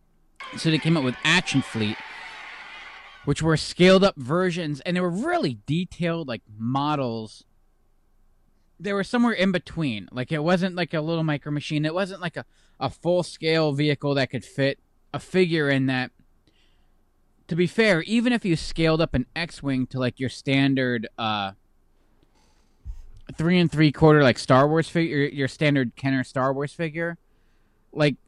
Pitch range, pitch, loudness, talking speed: 125-170 Hz, 145 Hz, -23 LUFS, 165 wpm